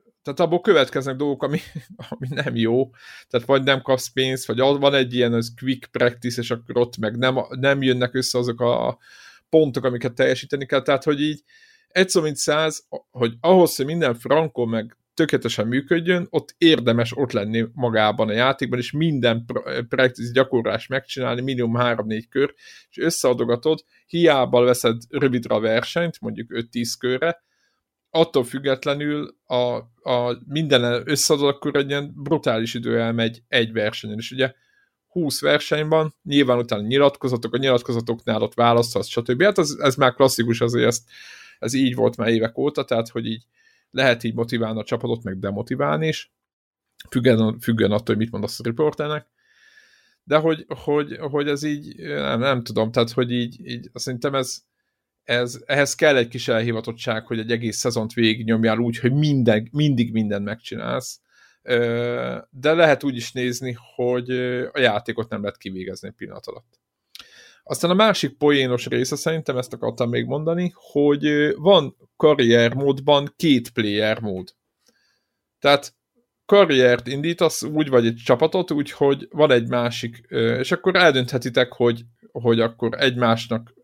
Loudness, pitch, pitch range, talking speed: -21 LUFS, 125 Hz, 115-145 Hz, 150 wpm